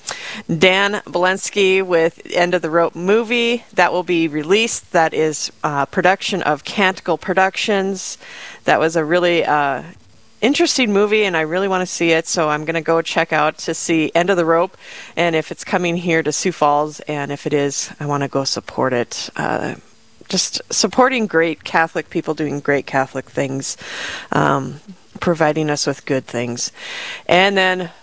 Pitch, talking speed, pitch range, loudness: 170 Hz, 175 wpm, 155-190 Hz, -17 LUFS